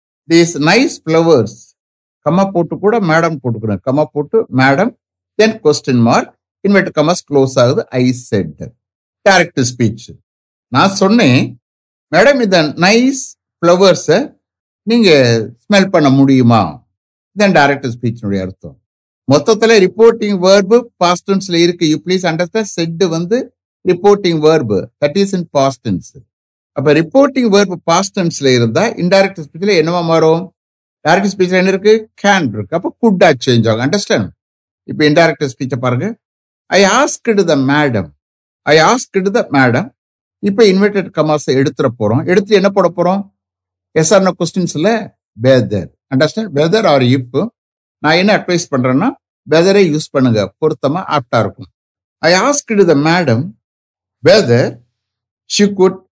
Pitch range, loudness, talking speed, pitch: 130-195 Hz, -12 LUFS, 105 wpm, 160 Hz